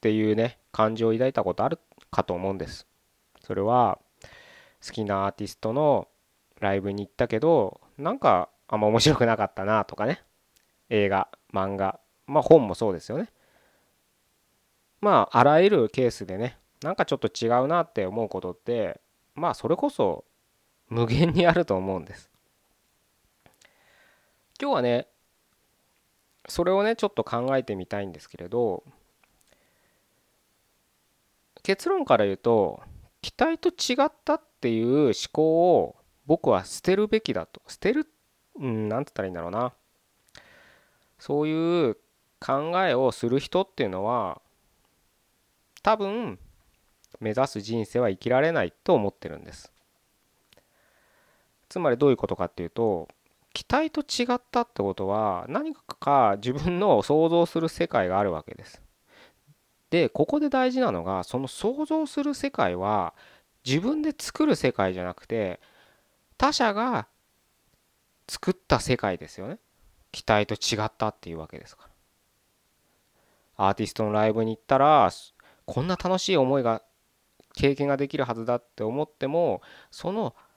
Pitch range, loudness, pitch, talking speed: 105-170 Hz, -25 LUFS, 125 Hz, 285 characters per minute